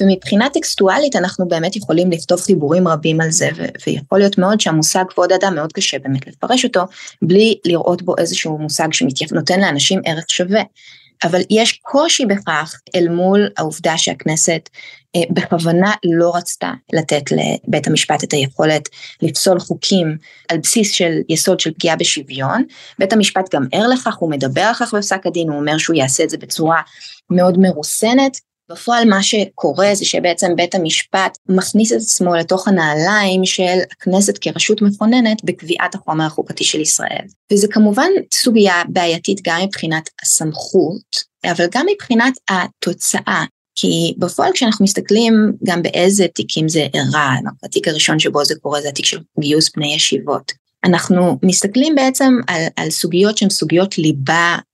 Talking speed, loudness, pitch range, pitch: 150 wpm, -15 LUFS, 160-205 Hz, 180 Hz